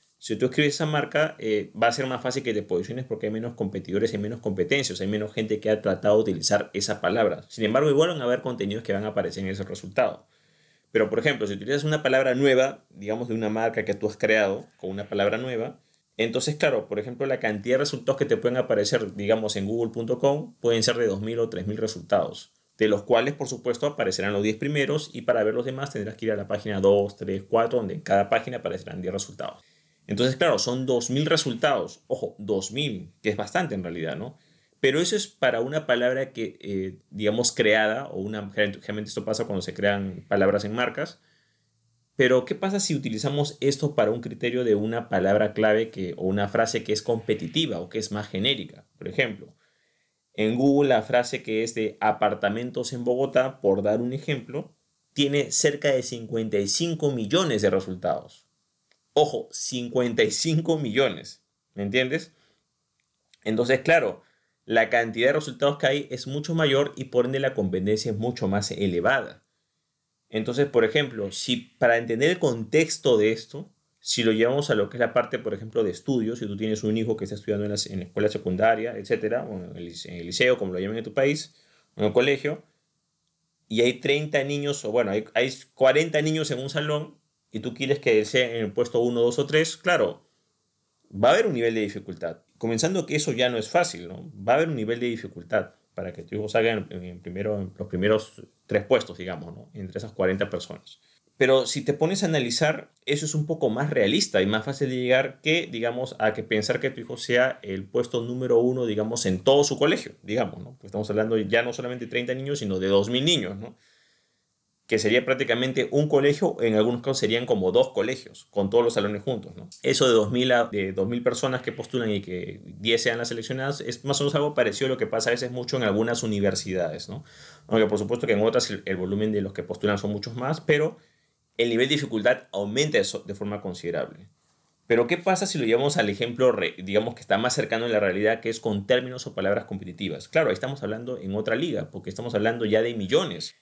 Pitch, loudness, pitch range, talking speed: 120 Hz, -25 LUFS, 105-140 Hz, 215 wpm